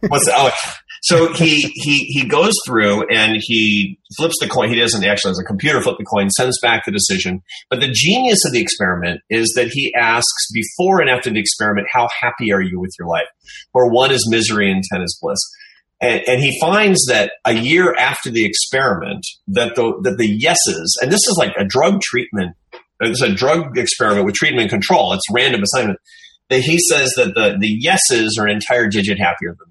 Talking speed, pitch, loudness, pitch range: 205 wpm, 120 Hz, -15 LUFS, 105-160 Hz